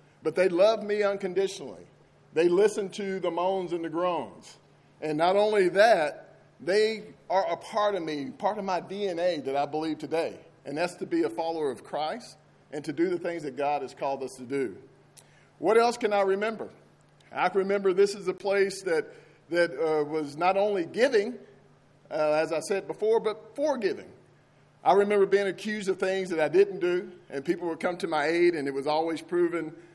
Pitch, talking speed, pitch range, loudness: 180 Hz, 195 wpm, 160-205 Hz, -27 LUFS